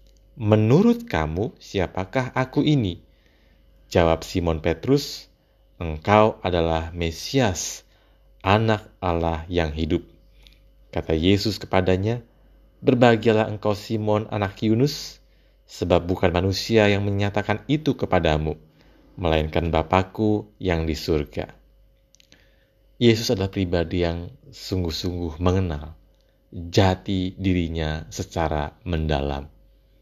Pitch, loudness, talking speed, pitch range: 95 Hz, -23 LUFS, 90 wpm, 80-110 Hz